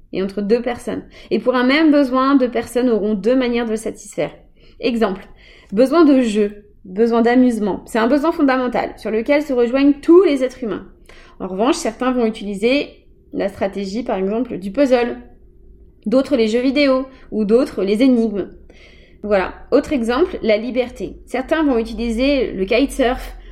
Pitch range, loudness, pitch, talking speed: 220-265 Hz, -17 LUFS, 245 Hz, 165 wpm